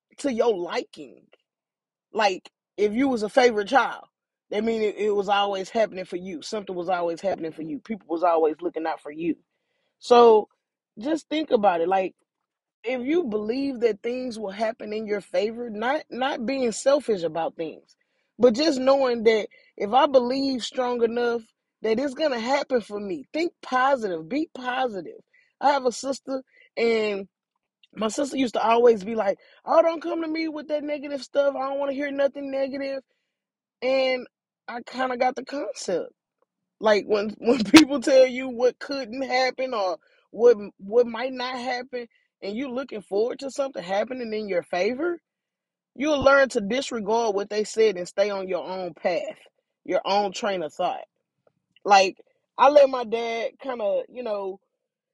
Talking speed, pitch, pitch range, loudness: 175 wpm, 245 Hz, 210-275 Hz, -24 LUFS